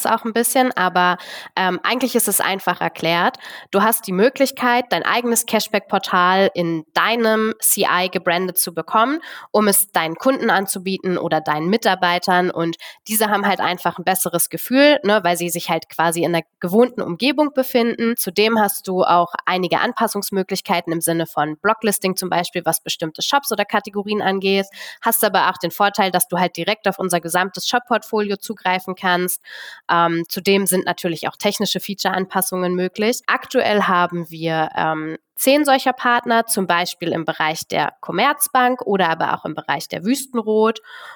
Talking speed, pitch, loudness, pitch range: 160 wpm, 195 Hz, -18 LUFS, 175-225 Hz